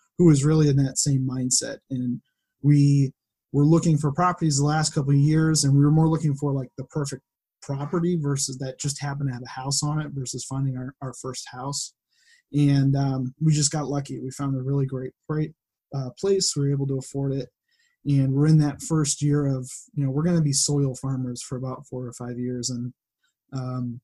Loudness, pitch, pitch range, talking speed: -24 LUFS, 140 Hz, 130-150 Hz, 215 wpm